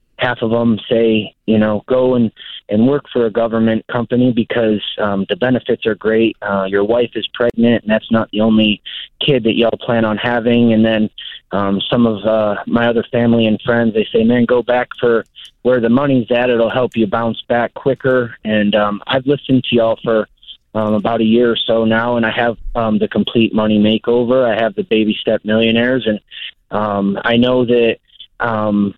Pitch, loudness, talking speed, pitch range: 115 Hz, -15 LUFS, 200 wpm, 110-120 Hz